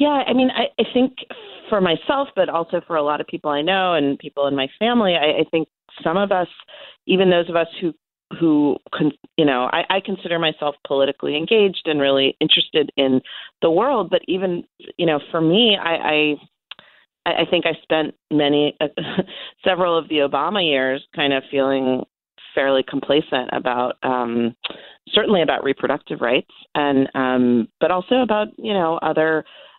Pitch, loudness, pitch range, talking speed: 160 Hz, -19 LUFS, 140-185 Hz, 175 wpm